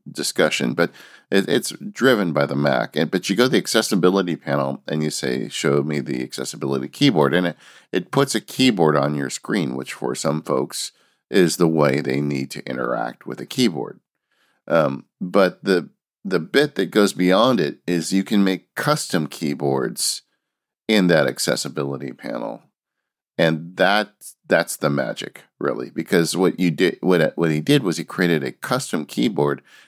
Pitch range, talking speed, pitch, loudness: 70-90 Hz, 175 wpm, 75 Hz, -21 LUFS